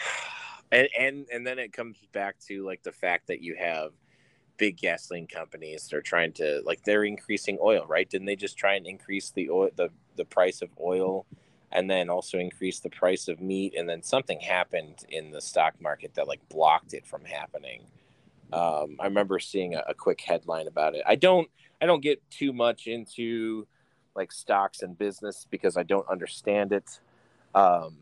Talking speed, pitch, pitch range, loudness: 190 wpm, 100 Hz, 95-120 Hz, -28 LUFS